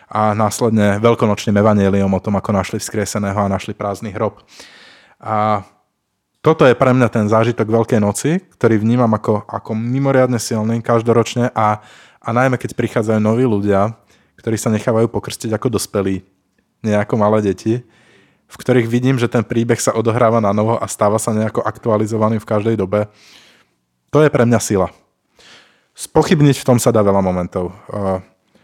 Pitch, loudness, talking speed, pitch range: 110 Hz, -16 LUFS, 155 wpm, 105-120 Hz